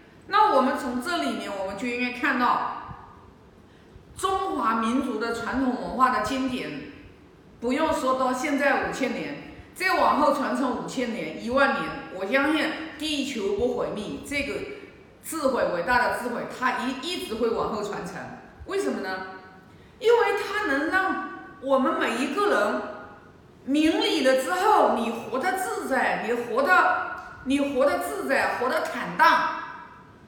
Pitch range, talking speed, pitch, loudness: 250-350 Hz, 215 characters per minute, 275 Hz, -25 LUFS